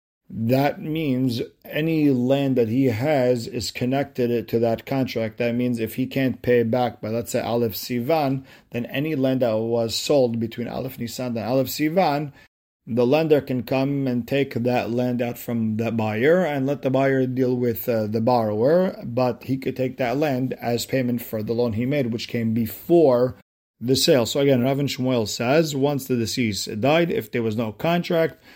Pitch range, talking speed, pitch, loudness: 115-135 Hz, 185 wpm, 125 Hz, -22 LUFS